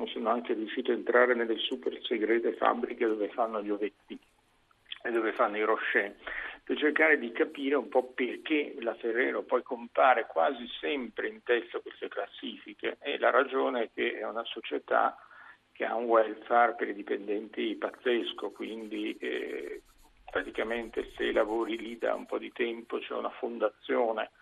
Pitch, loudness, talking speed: 160 Hz, -31 LUFS, 160 wpm